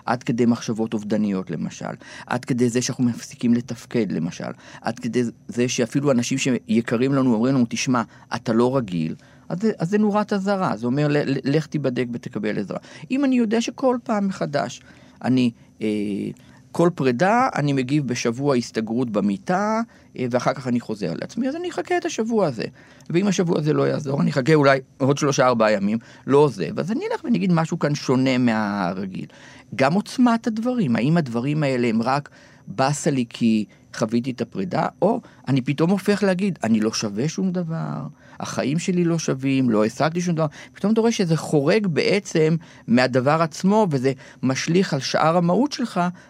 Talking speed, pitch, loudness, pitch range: 170 wpm, 140 Hz, -22 LUFS, 120-185 Hz